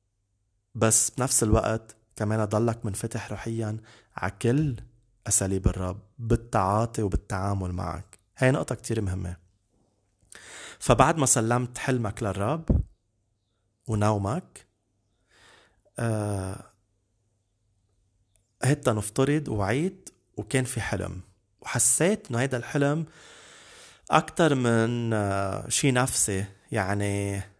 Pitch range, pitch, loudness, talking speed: 100-120 Hz, 110 Hz, -26 LUFS, 85 wpm